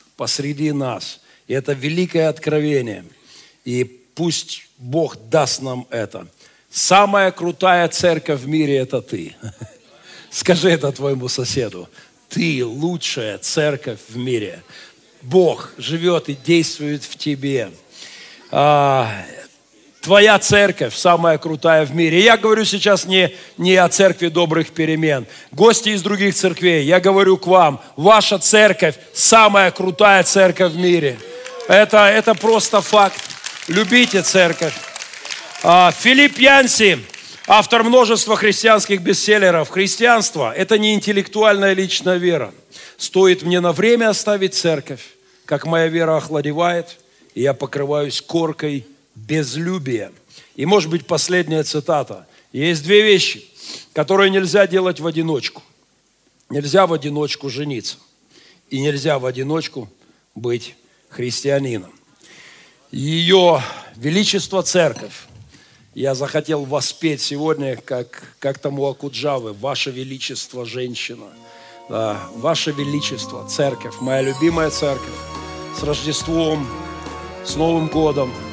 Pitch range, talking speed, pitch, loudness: 140-190 Hz, 110 wpm, 160 Hz, -16 LUFS